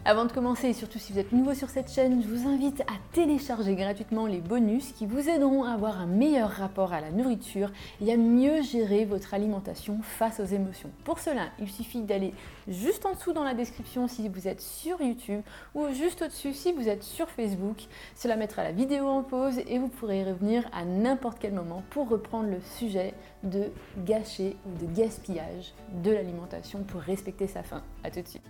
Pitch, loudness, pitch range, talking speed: 220 Hz, -30 LUFS, 200-260 Hz, 205 wpm